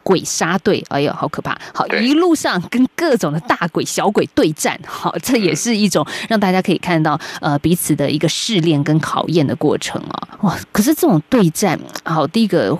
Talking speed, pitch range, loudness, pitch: 290 characters per minute, 160-235 Hz, -16 LUFS, 180 Hz